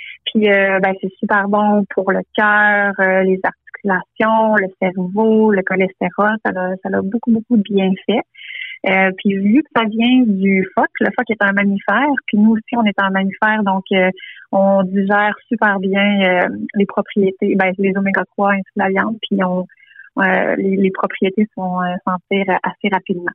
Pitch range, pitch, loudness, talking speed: 190-215 Hz, 200 Hz, -16 LUFS, 190 wpm